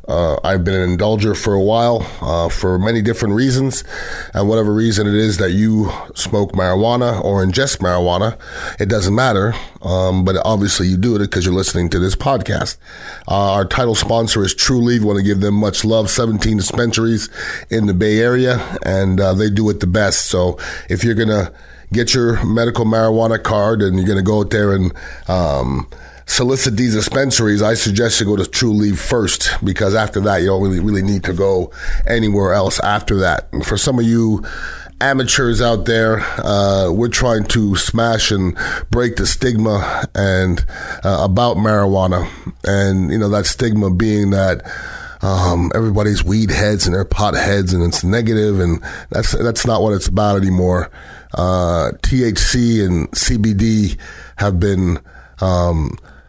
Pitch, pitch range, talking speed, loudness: 105 Hz, 95-115 Hz, 175 wpm, -15 LUFS